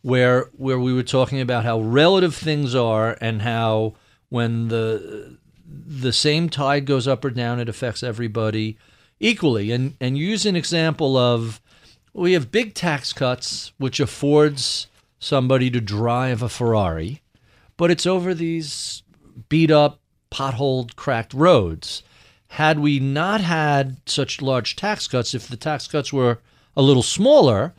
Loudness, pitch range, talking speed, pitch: -20 LUFS, 120-150 Hz, 145 wpm, 130 Hz